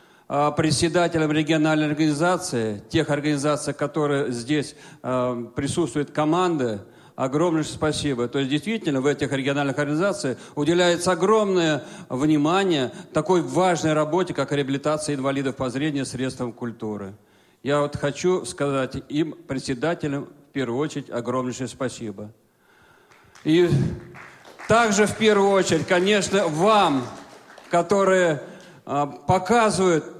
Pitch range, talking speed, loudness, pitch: 135-175 Hz, 105 wpm, -23 LUFS, 150 Hz